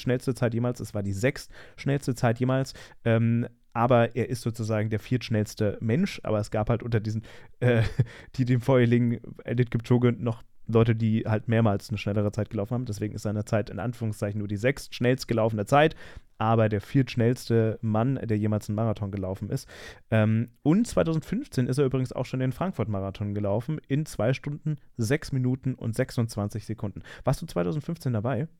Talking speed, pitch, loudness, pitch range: 175 wpm, 115 Hz, -27 LUFS, 110-130 Hz